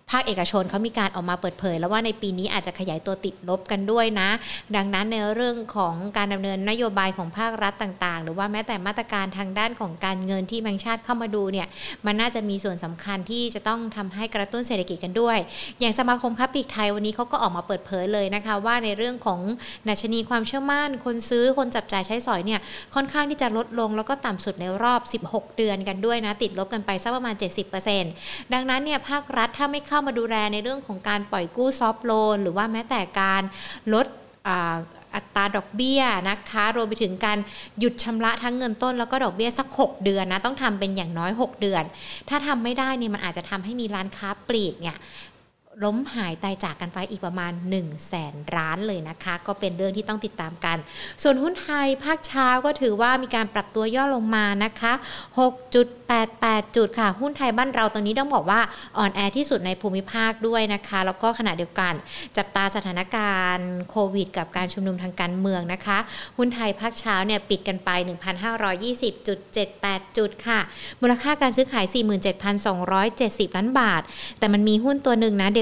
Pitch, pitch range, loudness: 210 Hz, 195-235 Hz, -24 LUFS